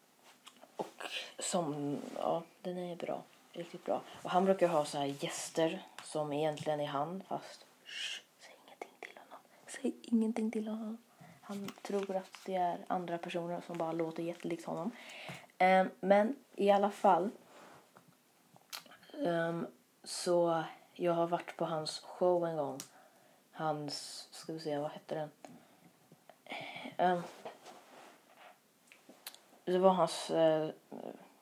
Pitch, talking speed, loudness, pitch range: 175 Hz, 130 wpm, -36 LUFS, 160-190 Hz